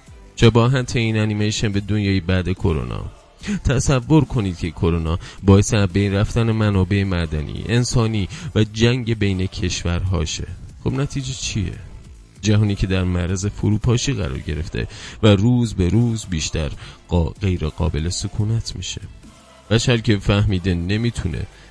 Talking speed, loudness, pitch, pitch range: 125 wpm, -20 LUFS, 100 Hz, 90-115 Hz